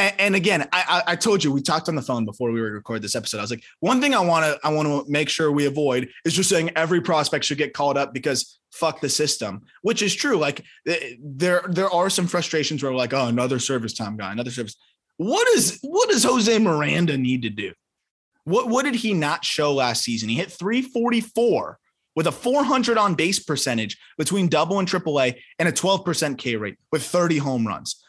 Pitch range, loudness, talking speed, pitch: 130-195 Hz, -22 LUFS, 220 wpm, 155 Hz